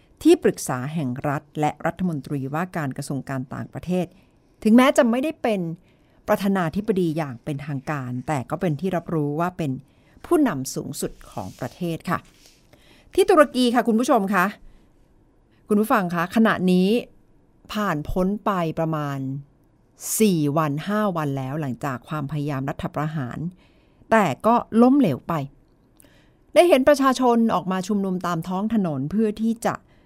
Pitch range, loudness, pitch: 150-215 Hz, -22 LUFS, 175 Hz